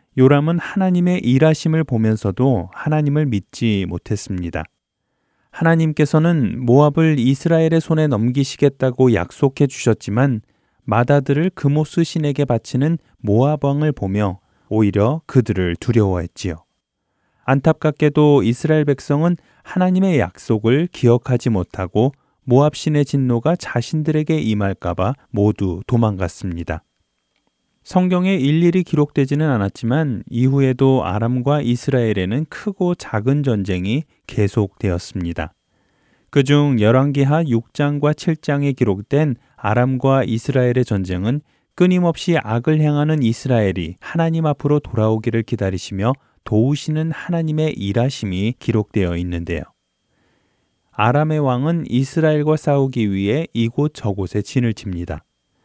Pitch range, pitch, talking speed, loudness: 110-150 Hz, 130 Hz, 300 characters per minute, -18 LUFS